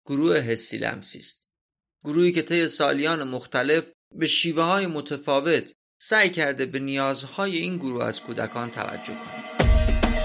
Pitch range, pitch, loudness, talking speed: 125-165 Hz, 145 Hz, -24 LUFS, 135 wpm